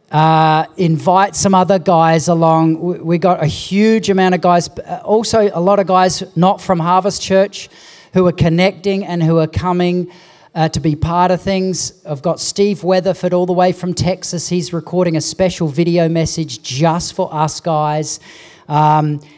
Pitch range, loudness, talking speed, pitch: 160-185 Hz, -14 LUFS, 175 wpm, 180 Hz